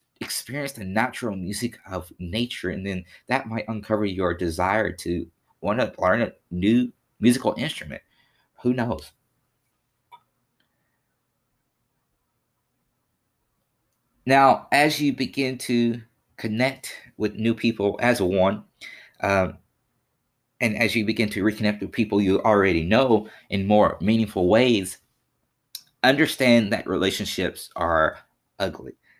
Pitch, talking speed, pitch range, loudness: 115 Hz, 115 wpm, 100-125 Hz, -23 LUFS